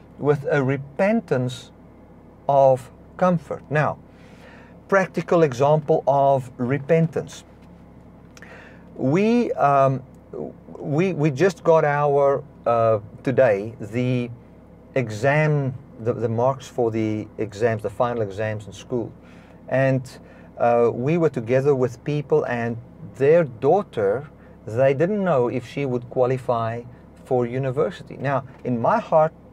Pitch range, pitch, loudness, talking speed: 120-155 Hz, 130 Hz, -22 LUFS, 110 wpm